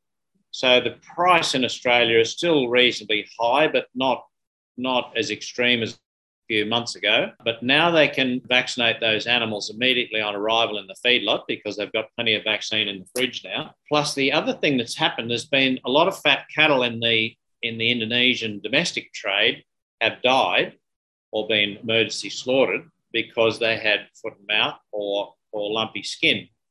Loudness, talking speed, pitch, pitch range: -21 LUFS, 175 wpm, 115 Hz, 110-125 Hz